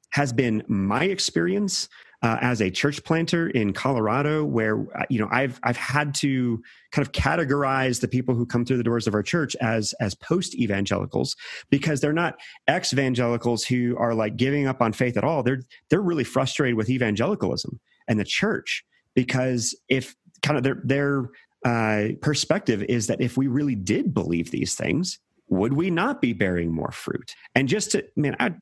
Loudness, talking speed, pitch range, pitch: -24 LUFS, 185 wpm, 115-145 Hz, 130 Hz